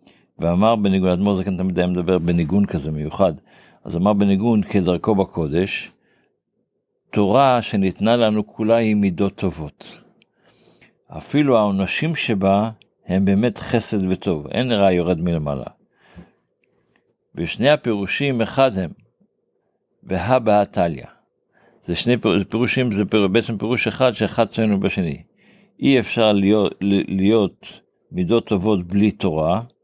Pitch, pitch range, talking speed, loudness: 100 Hz, 95-115 Hz, 115 wpm, -19 LUFS